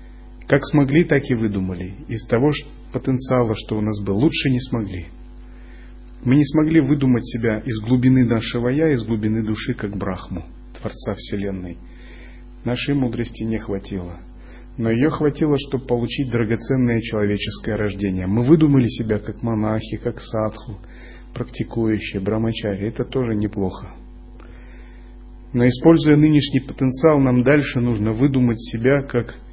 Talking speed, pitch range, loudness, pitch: 130 wpm, 105-130 Hz, -20 LUFS, 115 Hz